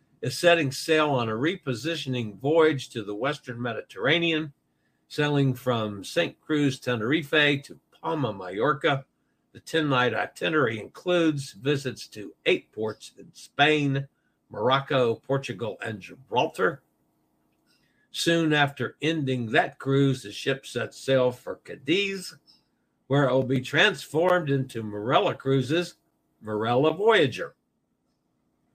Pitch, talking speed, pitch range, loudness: 135 Hz, 115 wpm, 125-155 Hz, -25 LUFS